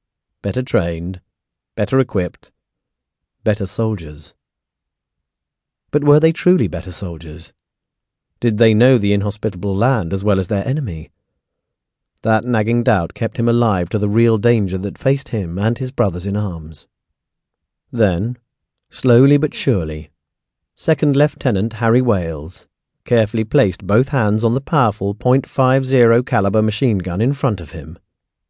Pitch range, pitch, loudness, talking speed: 95-125 Hz, 110 Hz, -17 LUFS, 135 wpm